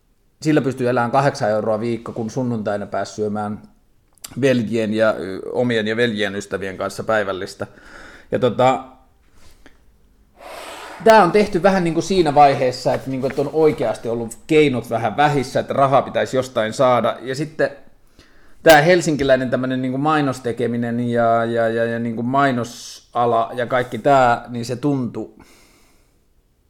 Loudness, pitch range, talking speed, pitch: -18 LUFS, 115-140 Hz, 140 wpm, 125 Hz